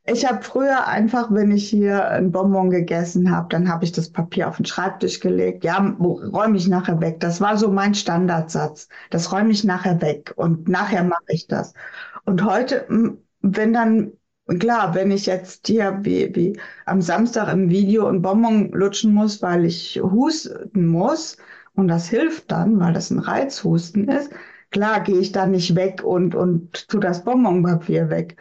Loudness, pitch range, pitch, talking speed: -20 LUFS, 175-215 Hz, 190 Hz, 175 wpm